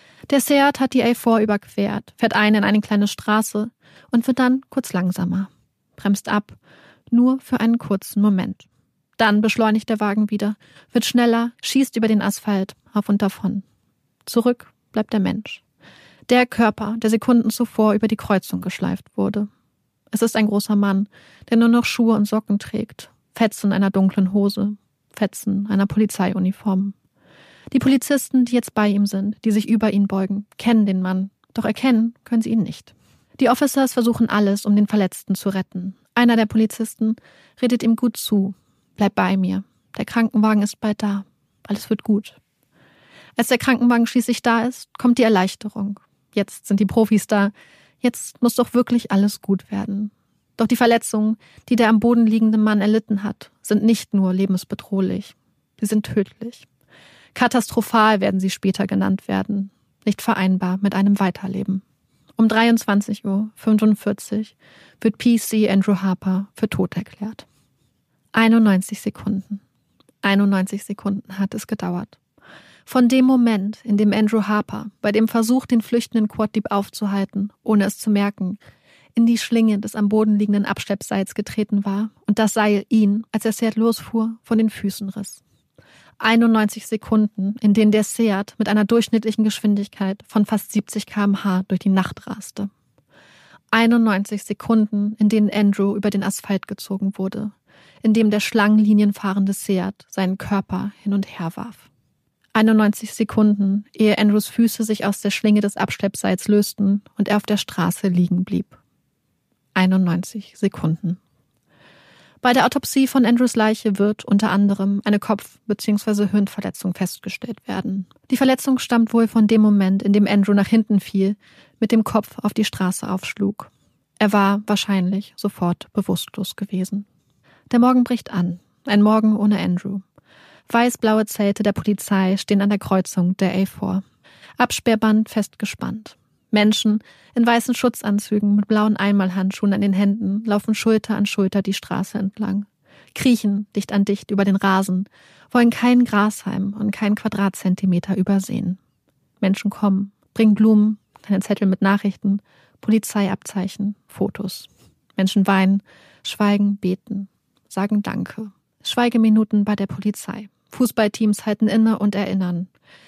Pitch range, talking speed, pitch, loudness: 195-220 Hz, 150 wpm, 210 Hz, -19 LUFS